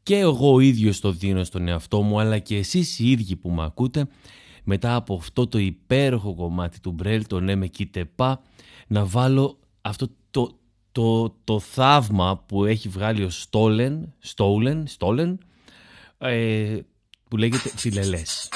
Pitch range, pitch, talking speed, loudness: 100-125 Hz, 110 Hz, 150 wpm, -23 LUFS